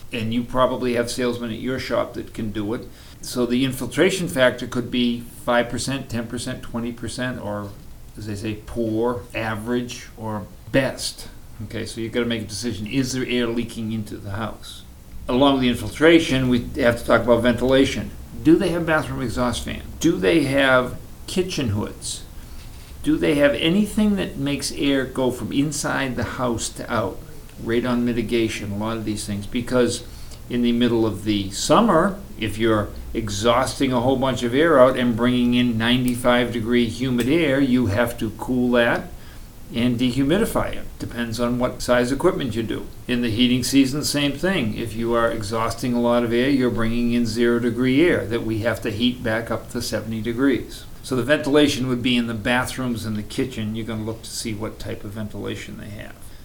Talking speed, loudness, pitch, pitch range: 190 wpm, -21 LUFS, 120 Hz, 115-130 Hz